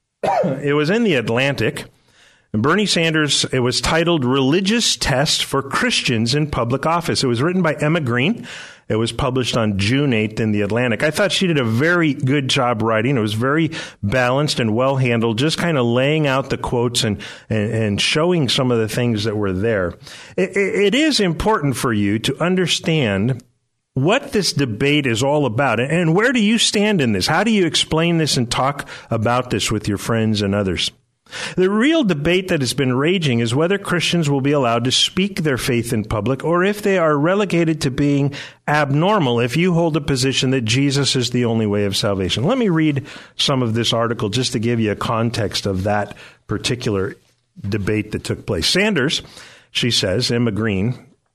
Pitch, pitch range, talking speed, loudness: 135 Hz, 115-160 Hz, 195 wpm, -18 LUFS